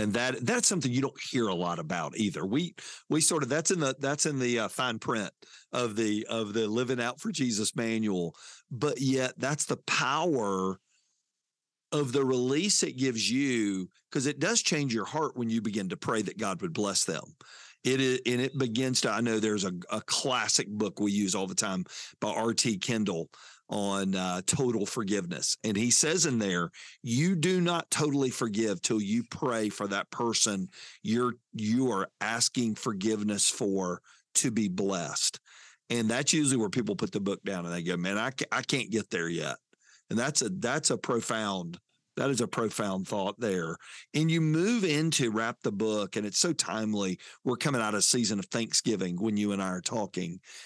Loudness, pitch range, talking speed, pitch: -29 LUFS, 105-130 Hz, 195 wpm, 115 Hz